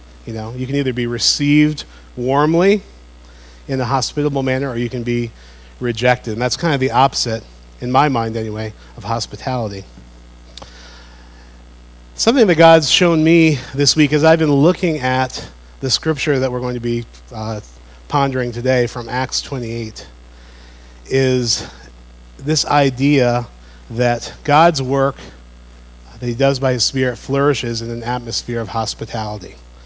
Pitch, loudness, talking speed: 120 Hz, -16 LUFS, 145 wpm